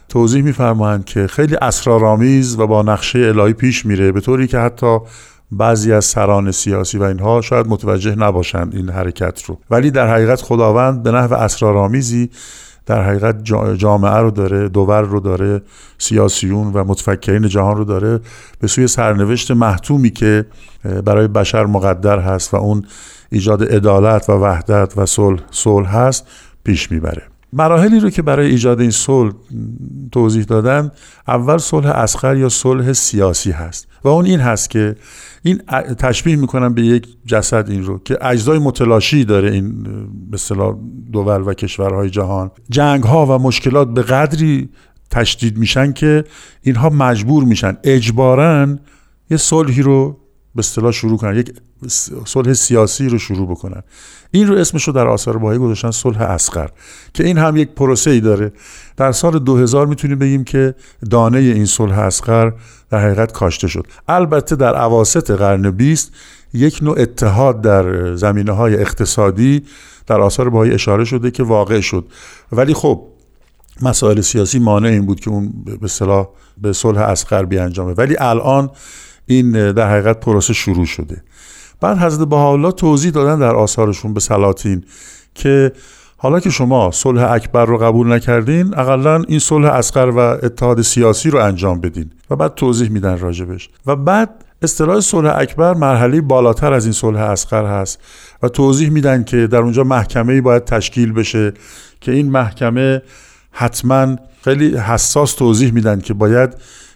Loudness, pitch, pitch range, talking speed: -13 LUFS, 115 Hz, 105-130 Hz, 155 wpm